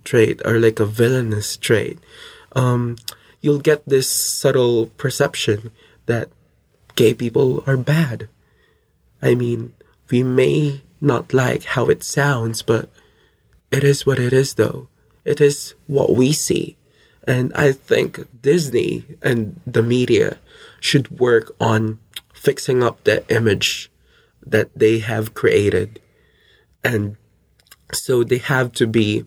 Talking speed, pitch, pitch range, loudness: 125 wpm, 125 Hz, 115-140 Hz, -18 LUFS